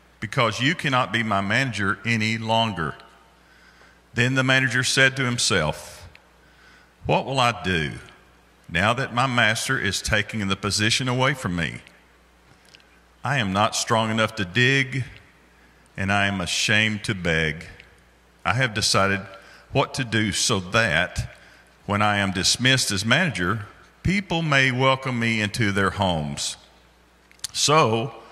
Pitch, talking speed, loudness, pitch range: 105 Hz, 135 wpm, -22 LUFS, 85-120 Hz